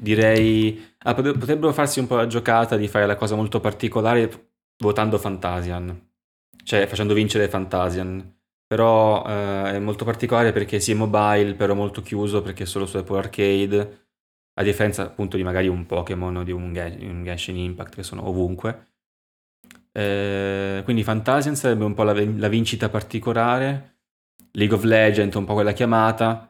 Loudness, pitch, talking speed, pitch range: -22 LUFS, 105 Hz, 160 wpm, 95-110 Hz